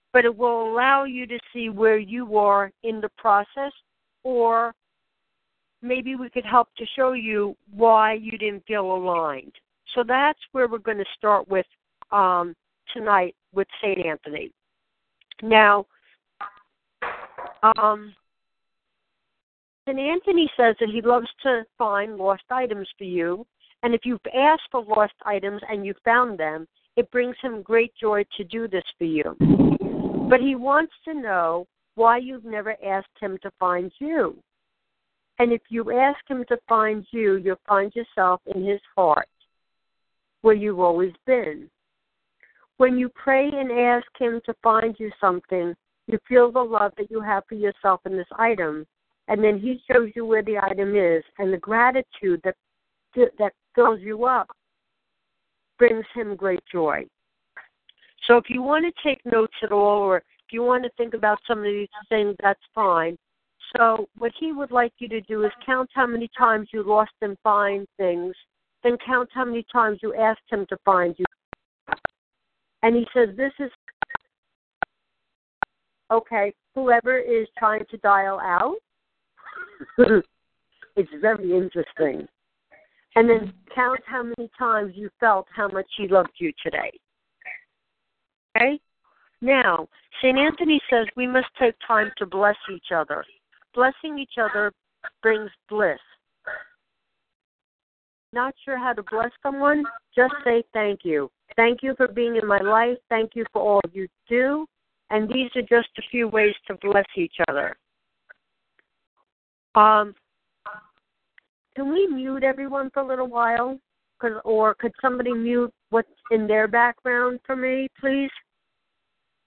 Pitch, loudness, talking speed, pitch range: 225 Hz, -22 LUFS, 150 wpm, 205-250 Hz